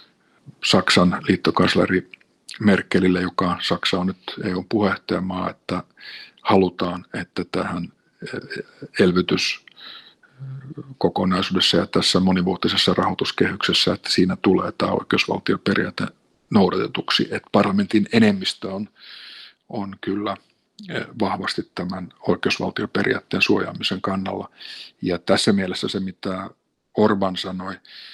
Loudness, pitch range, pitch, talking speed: -21 LUFS, 90-105 Hz, 95 Hz, 90 wpm